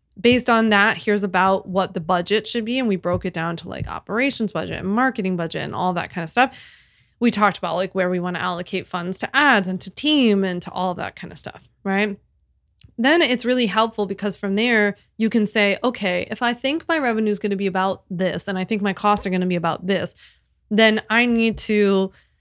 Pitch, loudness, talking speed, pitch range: 200 Hz, -20 LUFS, 240 wpm, 185-225 Hz